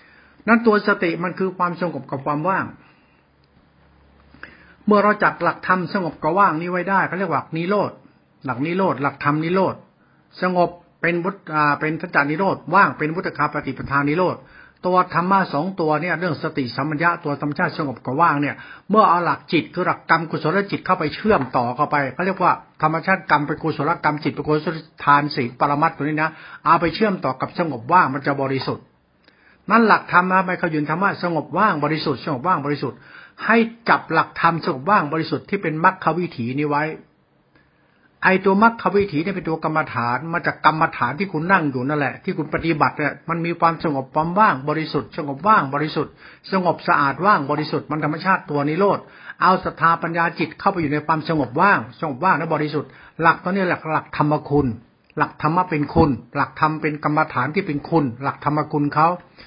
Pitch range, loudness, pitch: 145-180 Hz, -20 LUFS, 160 Hz